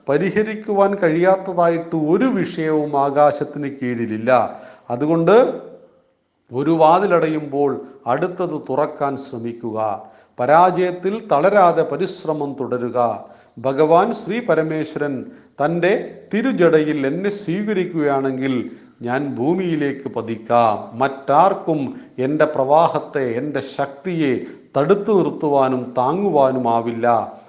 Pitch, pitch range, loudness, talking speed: 150 Hz, 135-180 Hz, -18 LUFS, 75 wpm